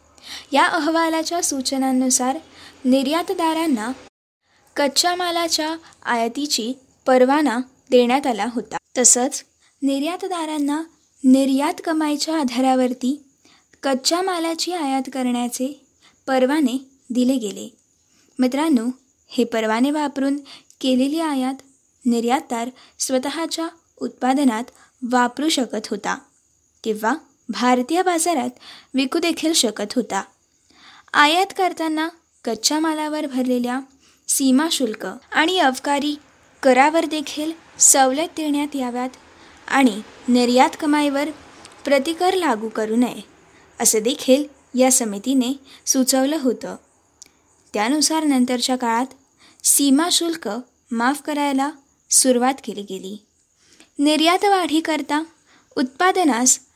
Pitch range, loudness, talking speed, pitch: 250-310 Hz, -20 LUFS, 85 wpm, 270 Hz